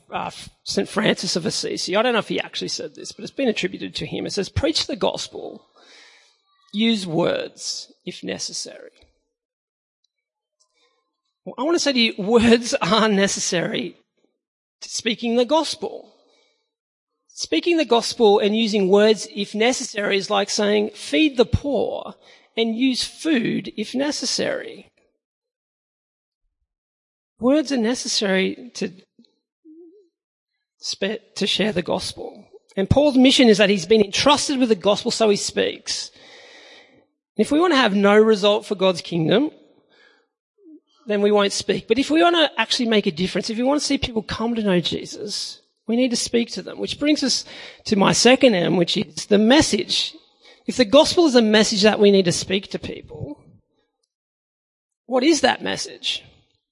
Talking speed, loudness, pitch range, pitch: 160 wpm, -19 LUFS, 205-310 Hz, 235 Hz